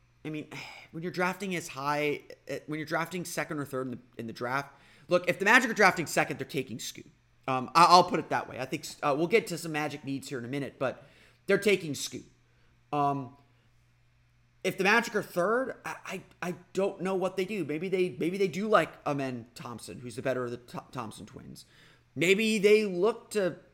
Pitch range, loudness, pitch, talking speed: 130-180 Hz, -29 LUFS, 150 Hz, 215 wpm